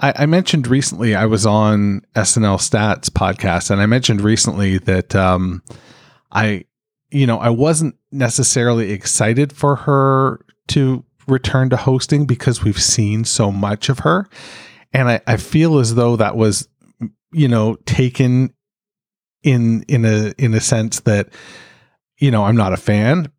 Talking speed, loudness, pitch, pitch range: 150 wpm, -16 LUFS, 120 Hz, 105-135 Hz